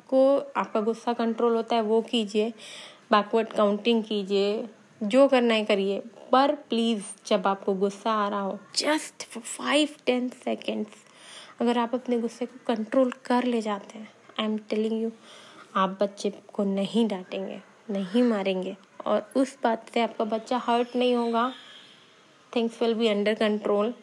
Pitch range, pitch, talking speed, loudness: 205-245 Hz, 225 Hz, 155 wpm, -26 LUFS